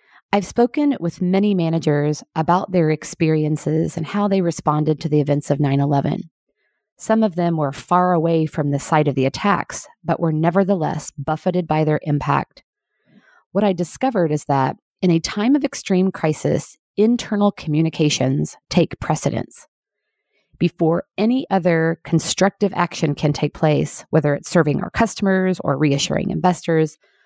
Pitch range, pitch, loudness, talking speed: 150-190 Hz, 165 Hz, -19 LUFS, 150 wpm